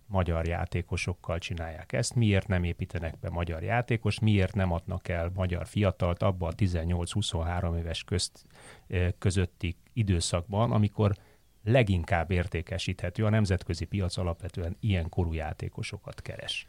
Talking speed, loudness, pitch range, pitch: 120 wpm, -30 LUFS, 85-105 Hz, 95 Hz